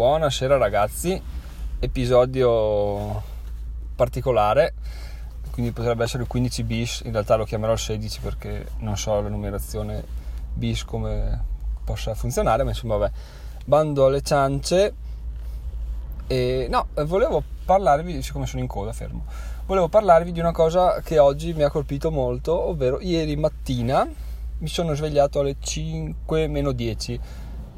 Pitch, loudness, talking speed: 115 Hz, -23 LUFS, 130 wpm